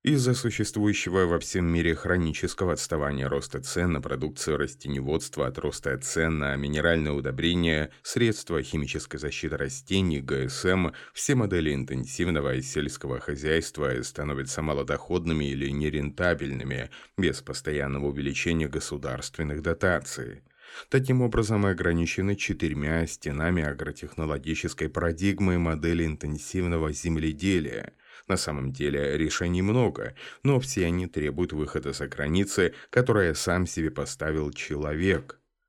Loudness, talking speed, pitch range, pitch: -28 LUFS, 110 wpm, 75-90 Hz, 80 Hz